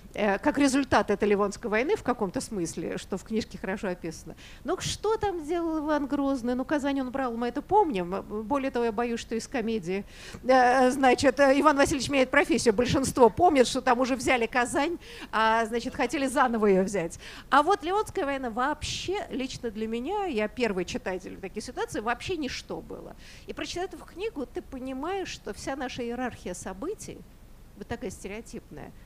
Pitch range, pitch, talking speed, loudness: 220-285 Hz, 255 Hz, 170 wpm, -27 LUFS